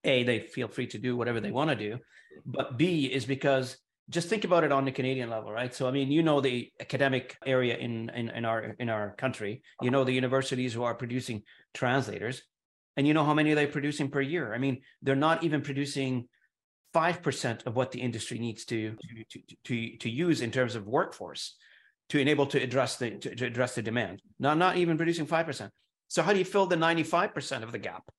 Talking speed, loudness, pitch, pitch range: 225 wpm, -30 LUFS, 135 Hz, 120-150 Hz